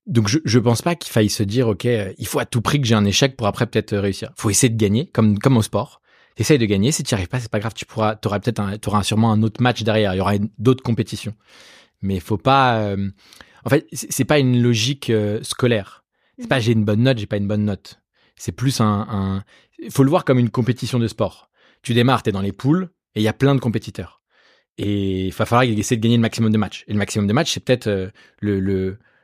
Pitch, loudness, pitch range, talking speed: 110 Hz, -19 LUFS, 105-125 Hz, 265 wpm